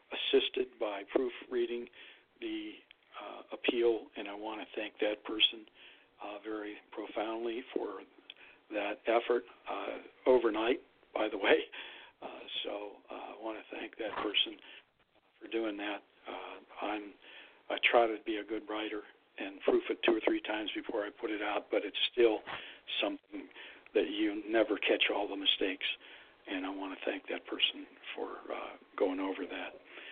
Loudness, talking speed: -34 LUFS, 160 wpm